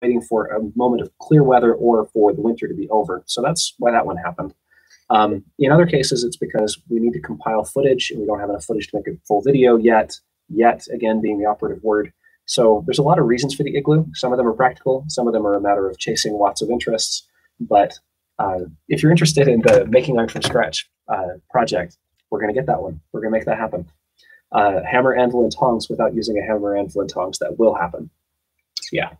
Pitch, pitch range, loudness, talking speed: 115 Hz, 105-130 Hz, -18 LUFS, 235 wpm